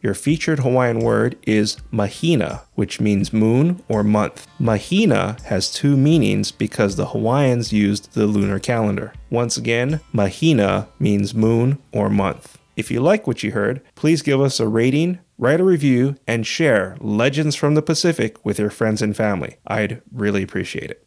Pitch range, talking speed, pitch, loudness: 105-145 Hz, 165 wpm, 115 Hz, -19 LUFS